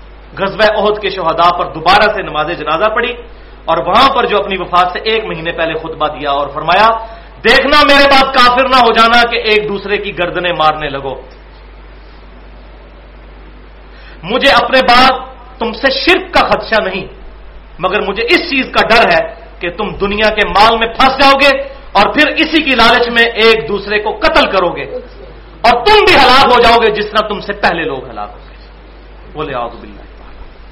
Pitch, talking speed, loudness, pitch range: 215 Hz, 180 wpm, -10 LUFS, 175-255 Hz